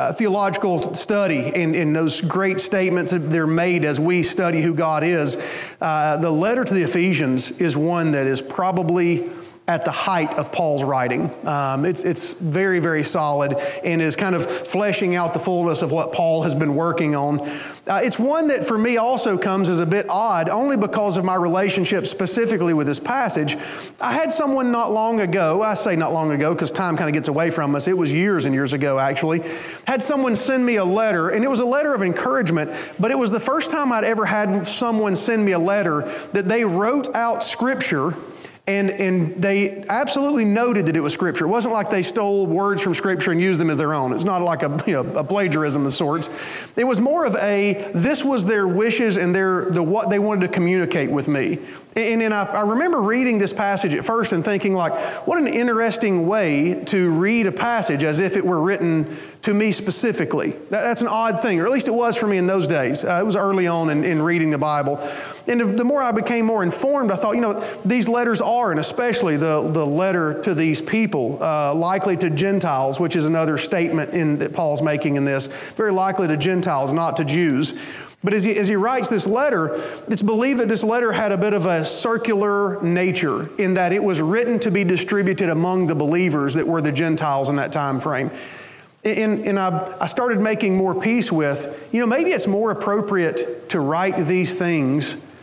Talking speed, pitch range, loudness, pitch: 215 wpm, 165-215 Hz, -20 LUFS, 185 Hz